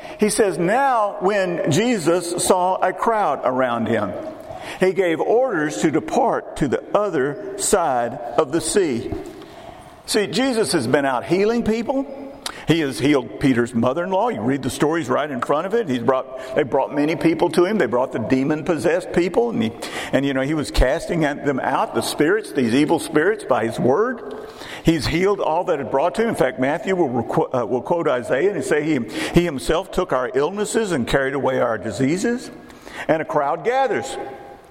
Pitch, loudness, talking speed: 175 Hz, -20 LUFS, 190 wpm